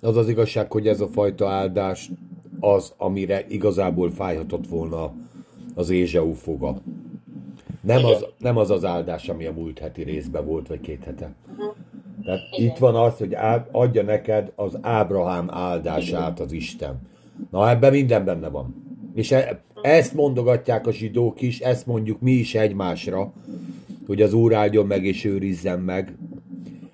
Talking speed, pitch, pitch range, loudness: 150 wpm, 105 Hz, 90-115 Hz, -22 LUFS